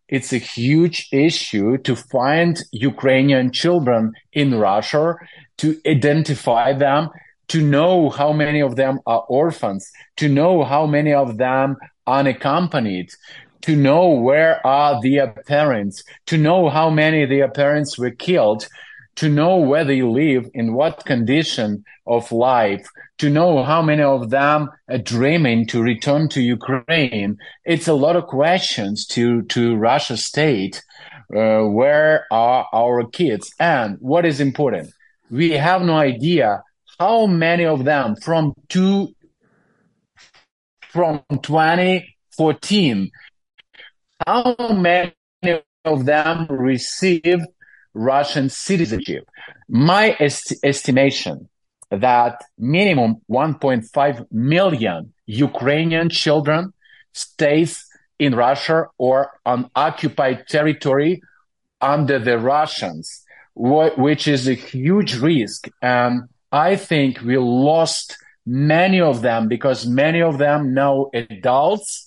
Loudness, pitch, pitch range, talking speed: -17 LUFS, 145 Hz, 125-160 Hz, 120 wpm